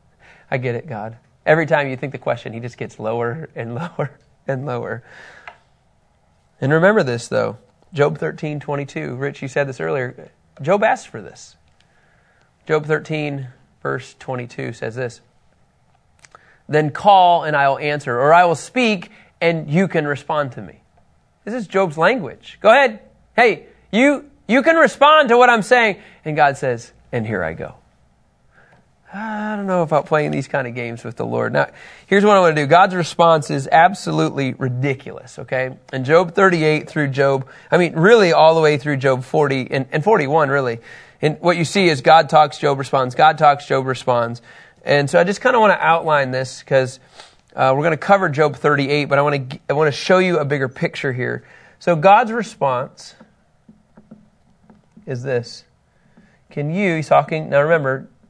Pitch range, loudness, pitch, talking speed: 130-170 Hz, -17 LUFS, 150 Hz, 185 wpm